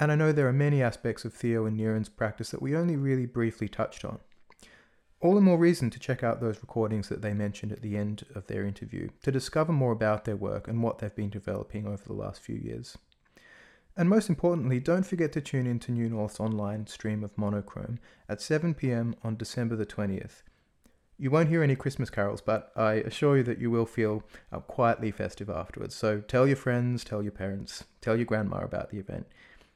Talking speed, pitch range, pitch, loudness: 215 wpm, 105-135 Hz, 115 Hz, -29 LUFS